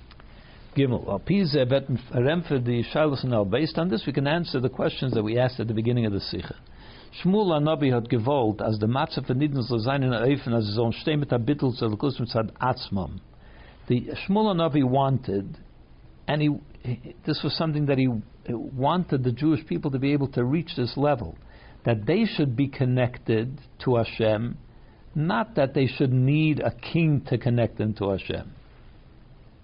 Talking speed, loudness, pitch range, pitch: 130 wpm, -25 LUFS, 115-150 Hz, 130 Hz